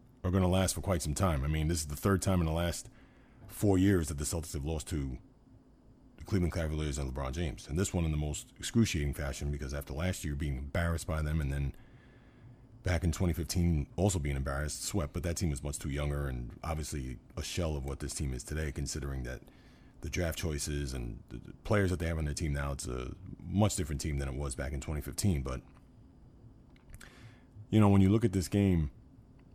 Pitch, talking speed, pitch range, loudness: 80 Hz, 220 wpm, 70-95 Hz, -33 LUFS